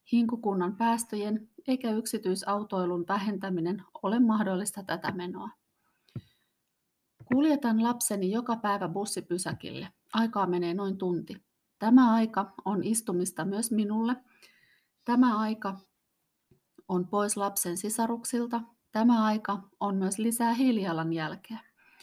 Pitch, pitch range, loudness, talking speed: 205 Hz, 190-230 Hz, -29 LUFS, 100 wpm